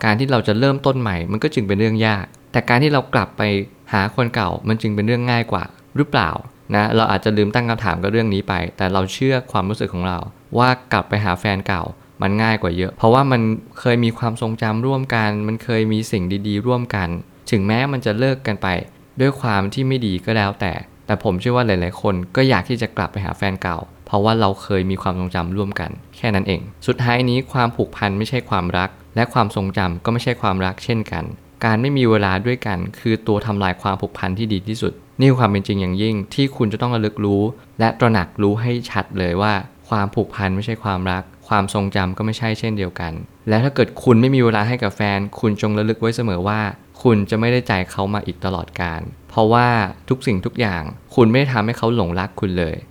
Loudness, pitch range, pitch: -19 LUFS, 95-120 Hz, 105 Hz